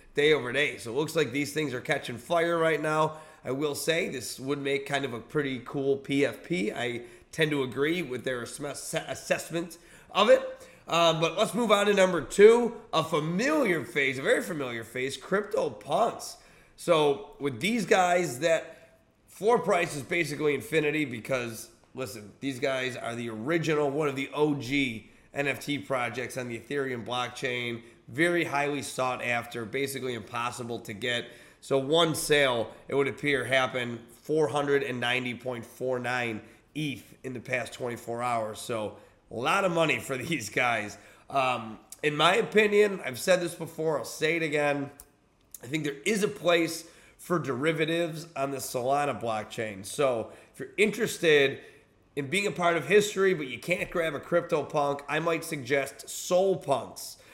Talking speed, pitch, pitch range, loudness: 160 wpm, 145 Hz, 125-170 Hz, -28 LUFS